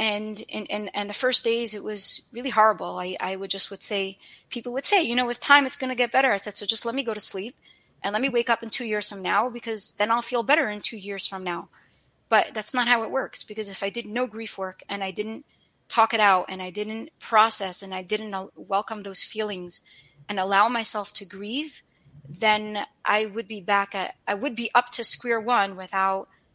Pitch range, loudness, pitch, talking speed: 195-235 Hz, -25 LUFS, 215 Hz, 235 wpm